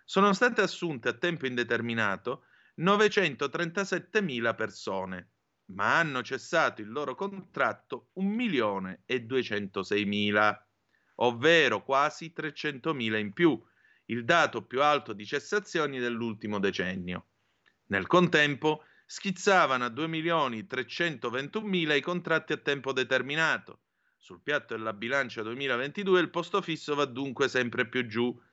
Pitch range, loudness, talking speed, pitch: 115-170 Hz, -29 LUFS, 105 wpm, 140 Hz